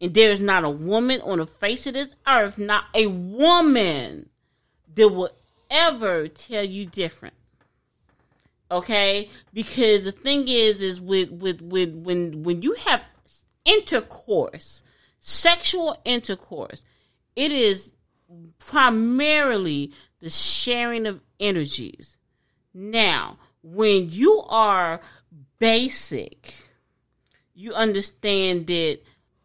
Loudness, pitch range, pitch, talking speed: -21 LUFS, 175-245 Hz, 205 Hz, 105 wpm